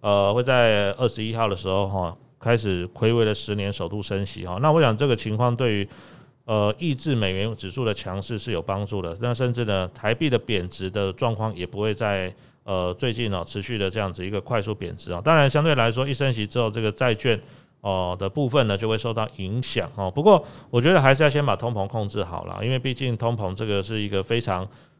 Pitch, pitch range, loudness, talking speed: 110 Hz, 100-125 Hz, -24 LUFS, 330 characters per minute